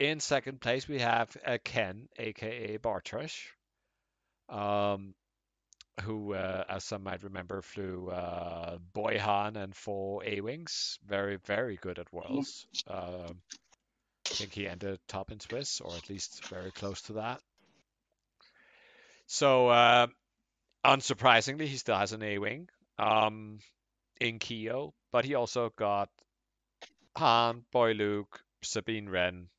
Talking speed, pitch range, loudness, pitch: 130 wpm, 95-120 Hz, -32 LUFS, 105 Hz